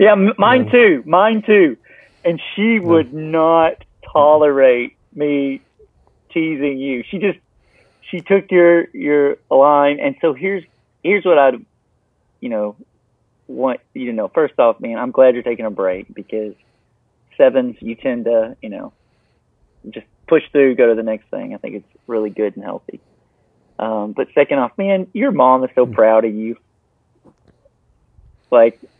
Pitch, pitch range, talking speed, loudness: 145 Hz, 115-185 Hz, 155 wpm, -15 LUFS